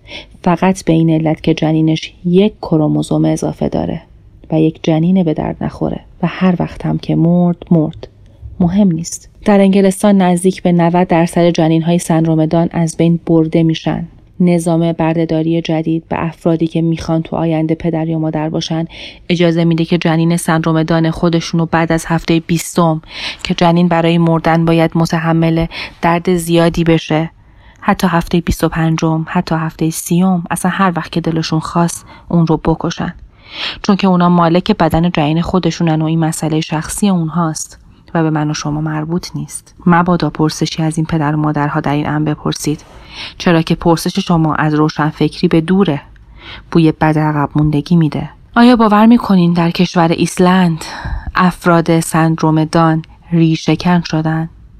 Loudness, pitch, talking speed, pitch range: -13 LUFS, 165 Hz, 155 wpm, 160-175 Hz